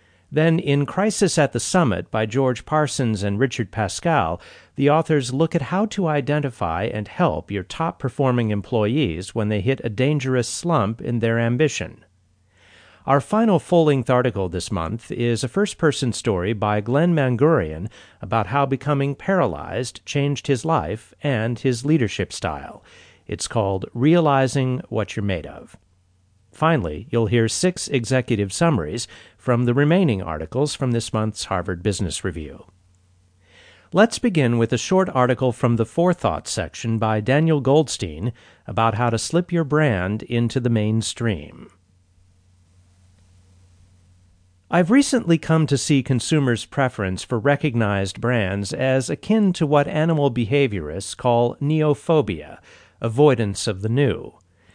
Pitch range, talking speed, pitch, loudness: 100-145 Hz, 140 wpm, 120 Hz, -21 LUFS